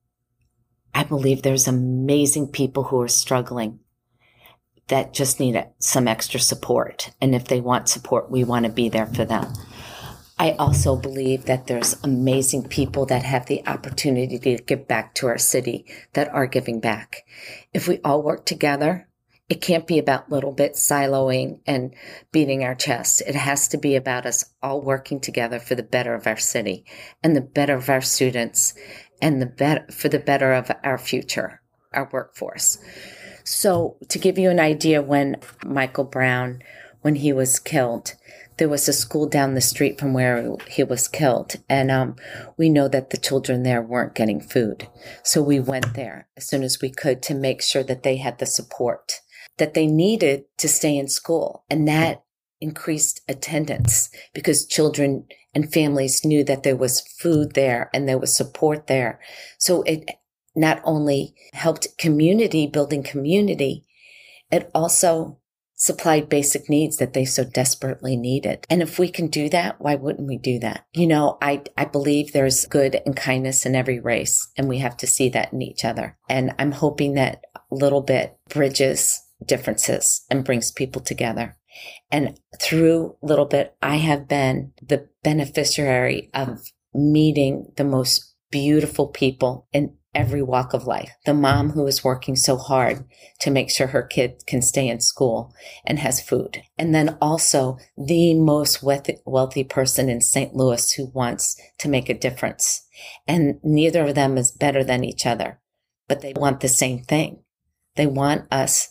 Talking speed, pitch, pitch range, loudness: 170 wpm, 135 Hz, 130-150 Hz, -21 LUFS